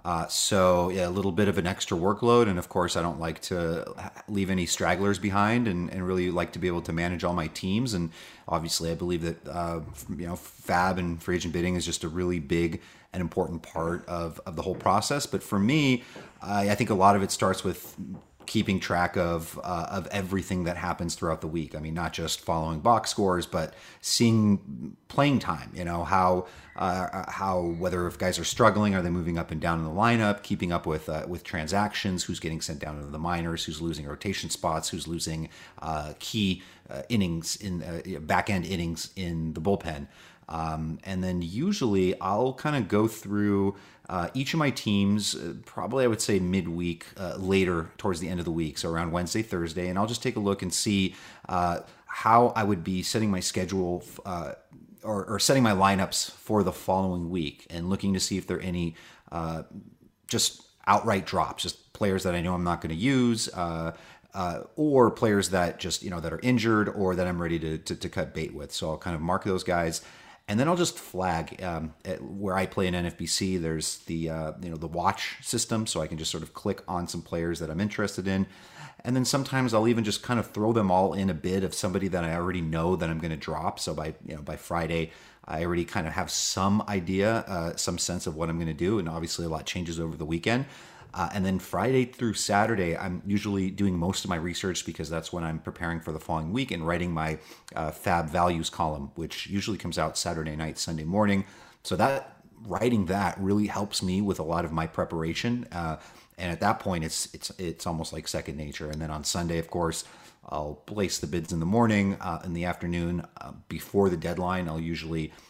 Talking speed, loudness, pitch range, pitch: 220 wpm, -28 LUFS, 85-100 Hz, 90 Hz